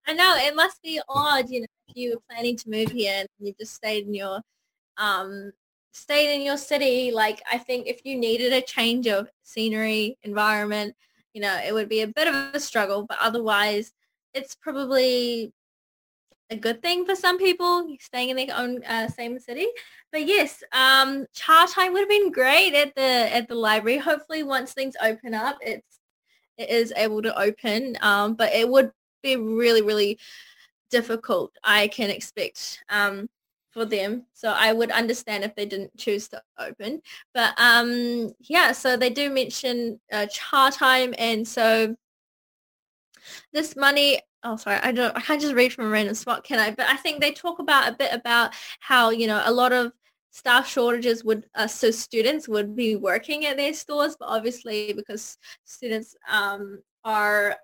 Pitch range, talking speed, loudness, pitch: 220-270 Hz, 180 wpm, -22 LUFS, 235 Hz